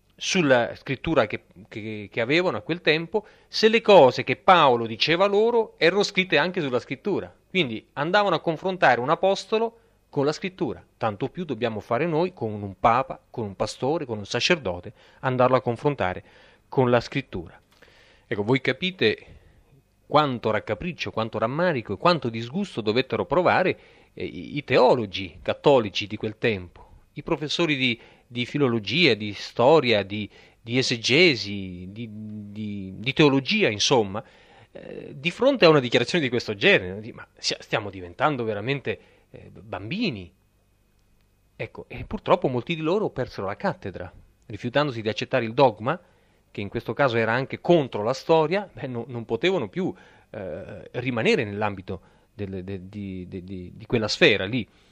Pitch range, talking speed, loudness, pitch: 105-155 Hz, 150 wpm, -23 LUFS, 120 Hz